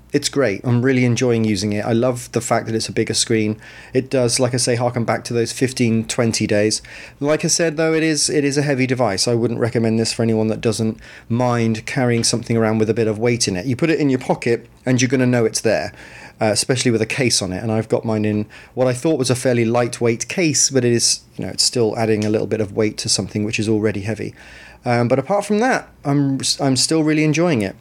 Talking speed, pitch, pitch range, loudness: 260 wpm, 120 Hz, 110-130 Hz, -18 LUFS